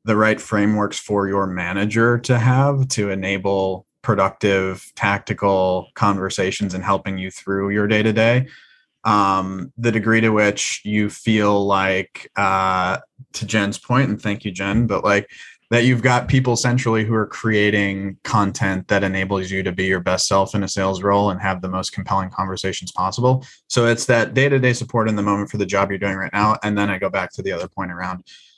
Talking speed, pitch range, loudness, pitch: 195 wpm, 95-115 Hz, -19 LUFS, 100 Hz